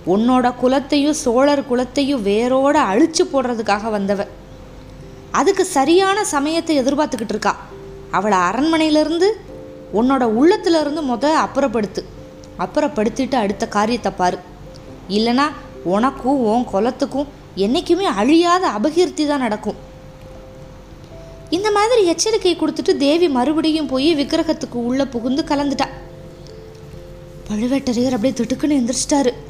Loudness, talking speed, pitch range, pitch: -17 LUFS, 100 wpm, 230-310 Hz, 275 Hz